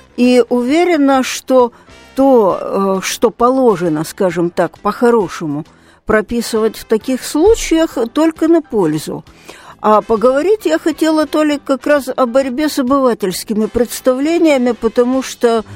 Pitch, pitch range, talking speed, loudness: 250 Hz, 220-290 Hz, 115 wpm, -14 LUFS